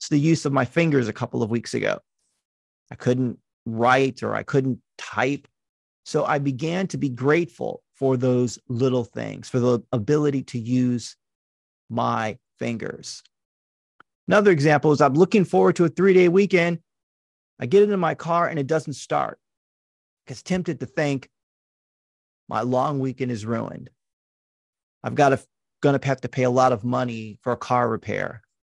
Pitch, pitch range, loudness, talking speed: 130 Hz, 115-150 Hz, -22 LUFS, 170 wpm